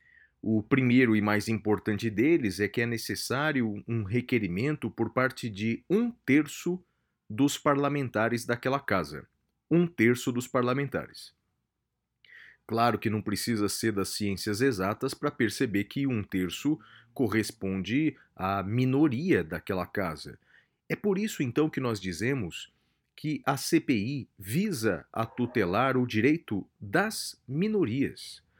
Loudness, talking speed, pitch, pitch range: -29 LUFS, 125 wpm, 120 Hz, 105-140 Hz